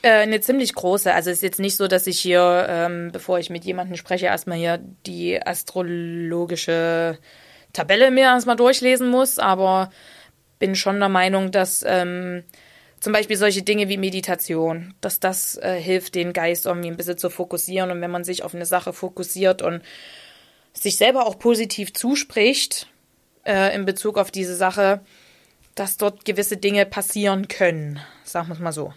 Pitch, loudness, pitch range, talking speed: 185 Hz, -20 LUFS, 175-200 Hz, 170 wpm